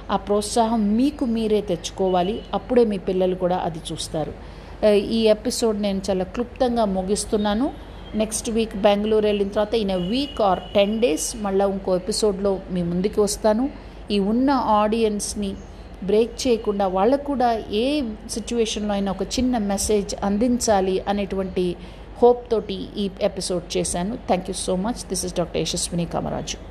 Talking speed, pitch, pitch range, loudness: 140 wpm, 210 Hz, 195-230 Hz, -22 LUFS